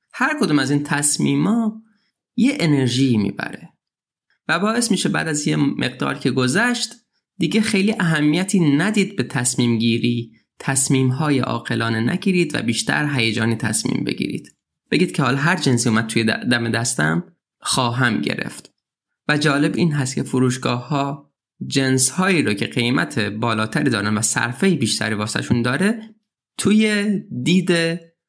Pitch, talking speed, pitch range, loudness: 140 Hz, 135 wpm, 120-180 Hz, -19 LUFS